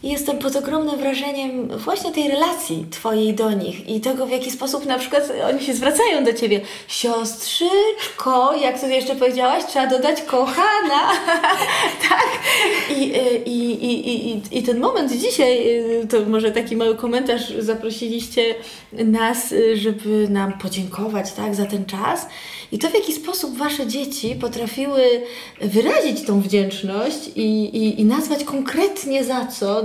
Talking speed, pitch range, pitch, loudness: 145 wpm, 225-280 Hz, 250 Hz, -19 LUFS